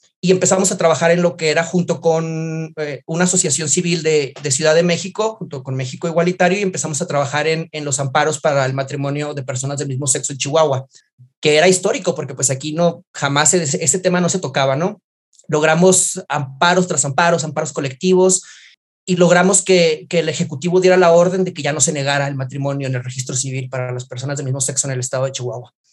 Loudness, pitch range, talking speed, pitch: -16 LUFS, 140-175 Hz, 220 wpm, 155 Hz